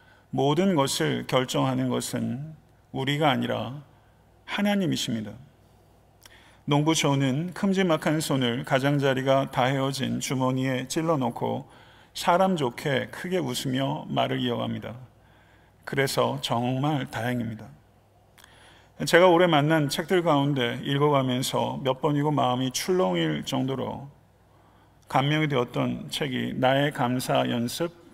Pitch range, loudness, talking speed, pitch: 120-145 Hz, -25 LUFS, 255 characters per minute, 130 Hz